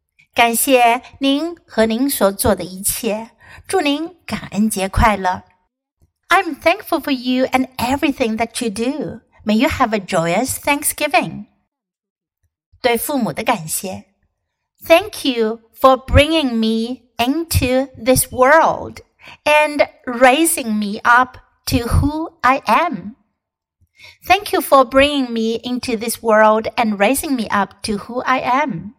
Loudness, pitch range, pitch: -16 LUFS, 220-285 Hz, 245 Hz